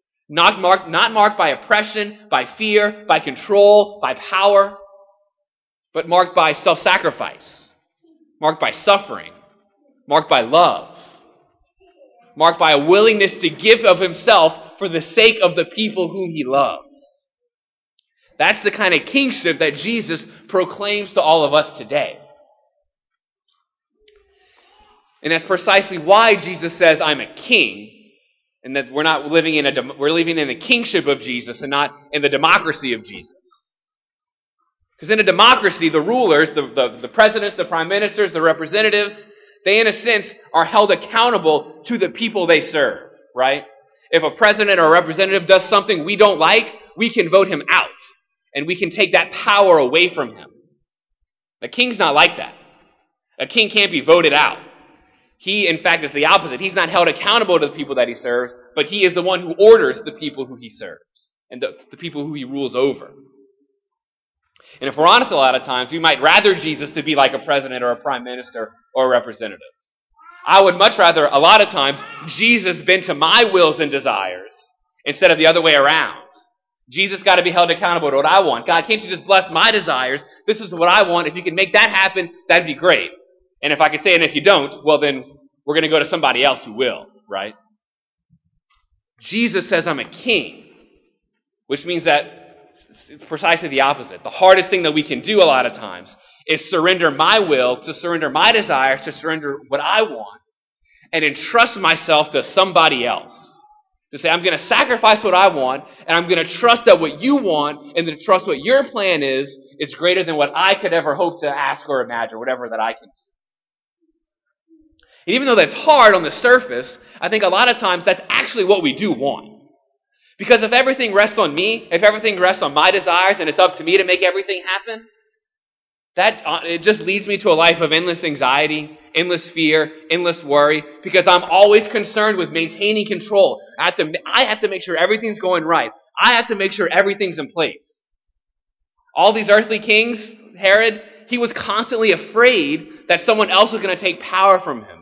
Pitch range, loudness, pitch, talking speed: 160-220 Hz, -15 LUFS, 190 Hz, 195 wpm